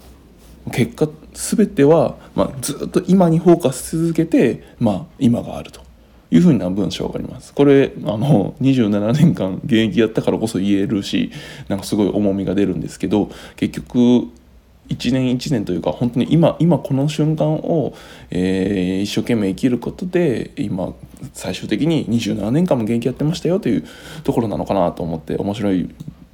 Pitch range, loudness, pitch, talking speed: 100-150 Hz, -18 LUFS, 120 Hz, 315 characters per minute